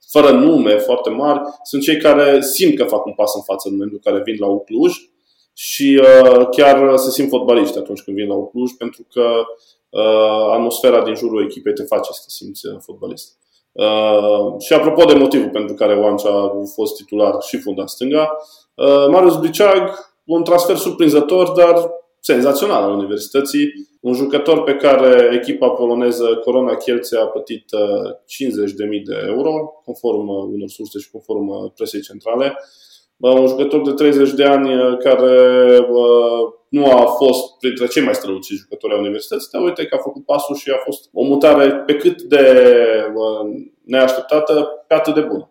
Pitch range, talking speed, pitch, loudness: 120-165 Hz, 165 wpm, 140 Hz, -14 LUFS